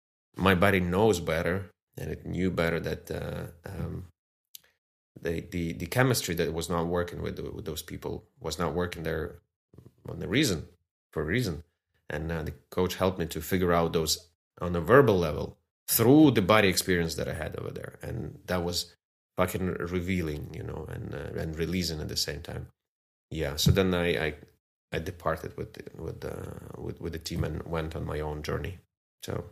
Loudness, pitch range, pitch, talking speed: -29 LUFS, 80-90 Hz, 85 Hz, 185 wpm